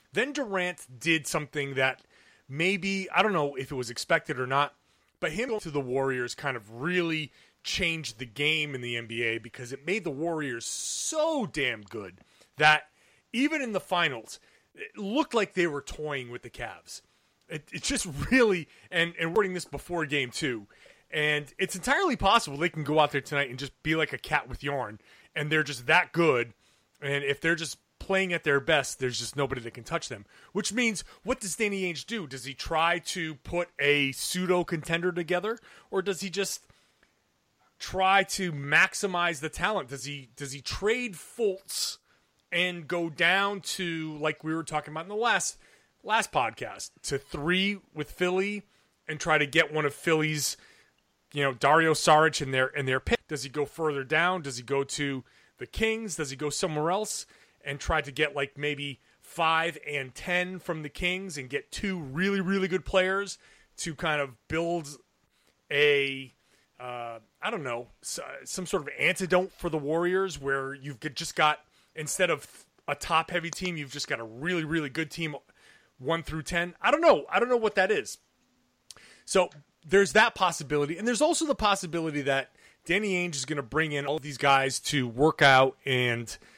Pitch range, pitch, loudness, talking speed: 140-185 Hz, 160 Hz, -28 LUFS, 190 wpm